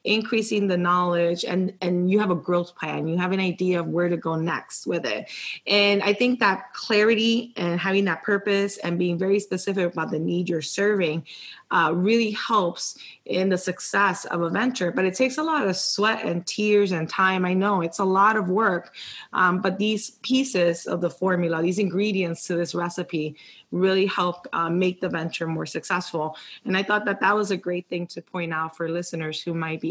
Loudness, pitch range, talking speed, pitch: -24 LUFS, 170-200 Hz, 205 wpm, 185 Hz